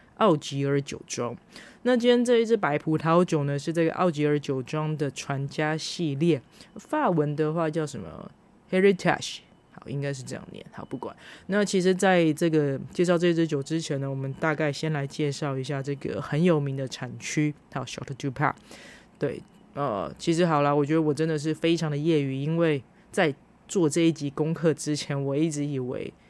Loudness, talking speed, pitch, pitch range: -26 LUFS, 305 characters per minute, 155 Hz, 140-170 Hz